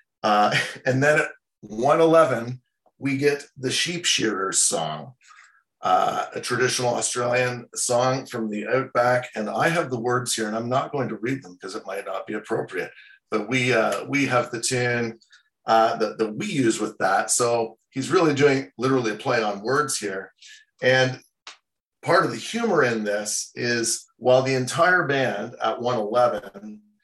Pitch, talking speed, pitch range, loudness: 125 Hz, 170 wpm, 115-140 Hz, -23 LUFS